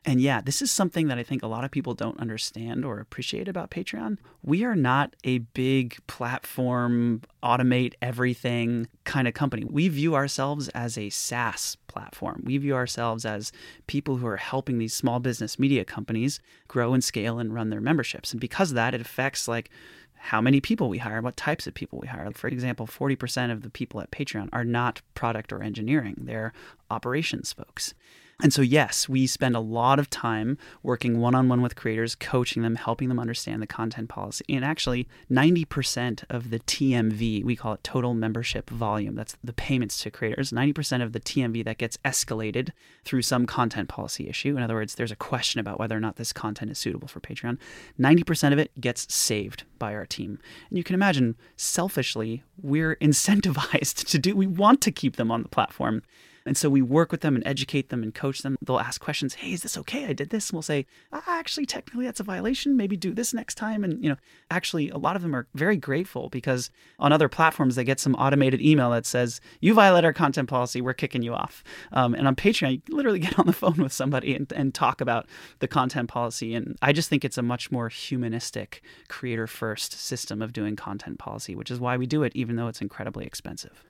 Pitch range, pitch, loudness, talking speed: 115-145 Hz, 125 Hz, -26 LUFS, 210 wpm